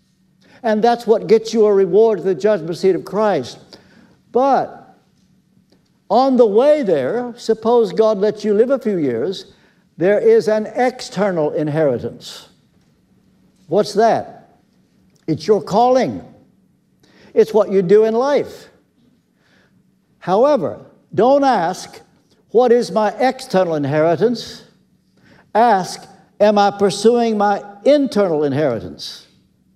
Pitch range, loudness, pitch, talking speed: 195-240 Hz, -16 LUFS, 215 Hz, 115 wpm